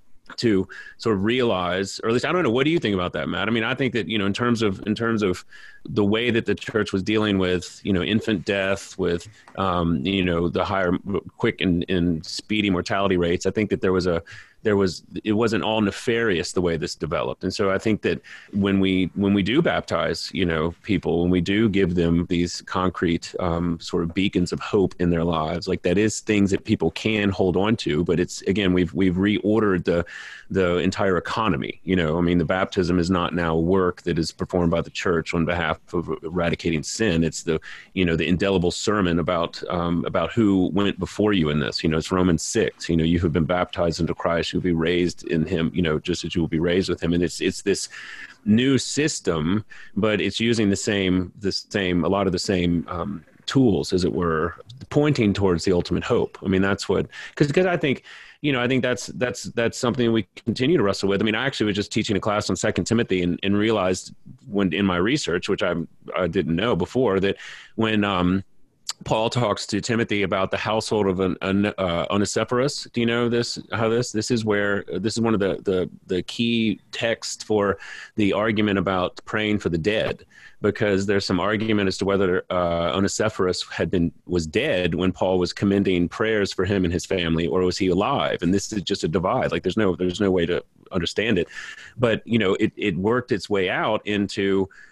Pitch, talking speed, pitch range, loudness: 95 Hz, 225 wpm, 90-105 Hz, -23 LUFS